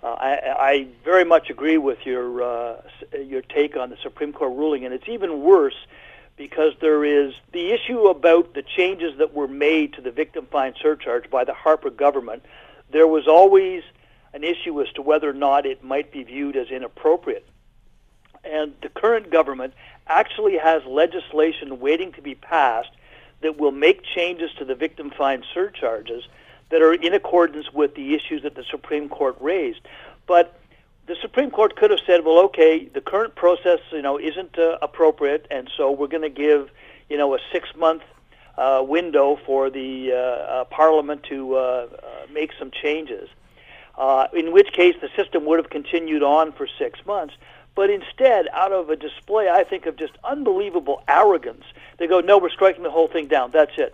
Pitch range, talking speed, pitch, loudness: 145-190 Hz, 180 wpm, 160 Hz, -20 LUFS